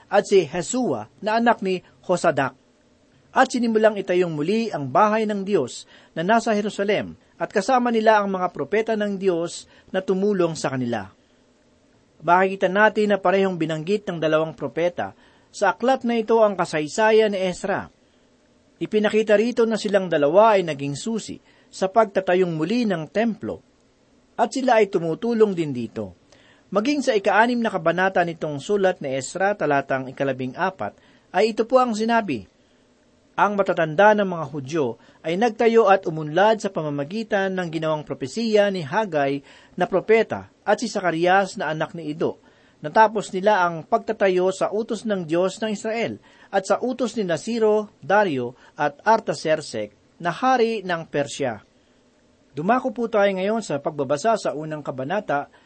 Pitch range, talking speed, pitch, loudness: 160-220 Hz, 150 wpm, 190 Hz, -22 LUFS